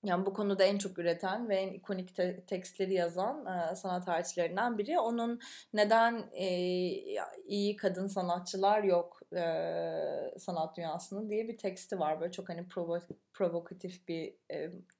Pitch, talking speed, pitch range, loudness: 190 Hz, 145 wpm, 175-205 Hz, -34 LUFS